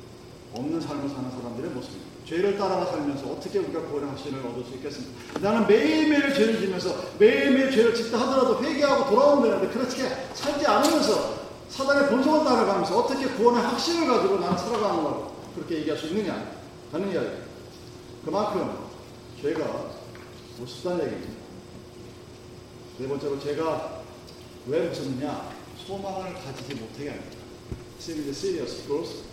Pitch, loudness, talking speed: 195 Hz, -25 LUFS, 360 characters per minute